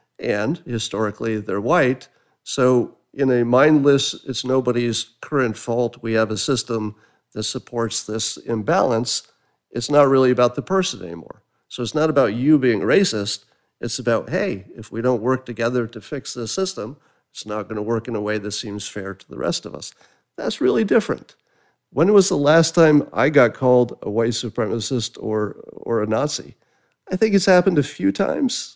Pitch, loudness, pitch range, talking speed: 120 Hz, -20 LUFS, 110-145 Hz, 180 wpm